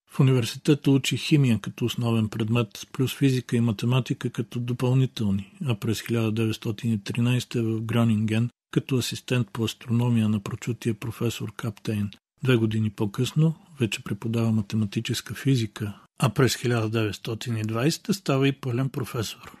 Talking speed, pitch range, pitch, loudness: 125 wpm, 110-130 Hz, 120 Hz, -26 LUFS